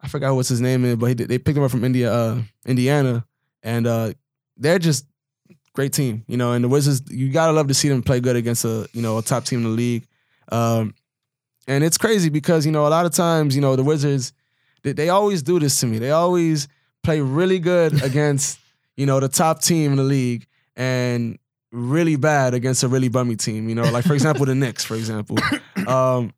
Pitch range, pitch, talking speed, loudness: 120-150 Hz, 135 Hz, 225 wpm, -20 LUFS